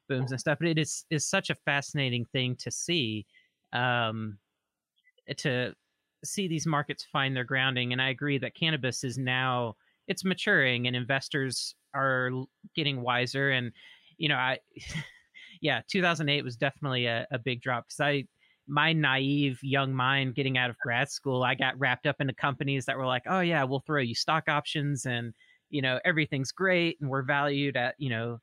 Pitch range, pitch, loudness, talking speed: 125-150 Hz, 135 Hz, -29 LUFS, 180 wpm